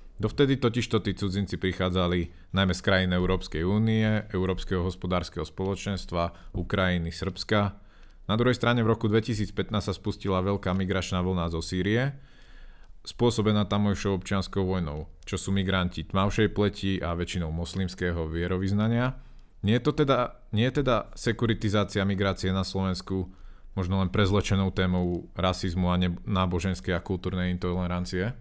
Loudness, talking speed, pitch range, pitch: -27 LUFS, 135 wpm, 90-105 Hz, 95 Hz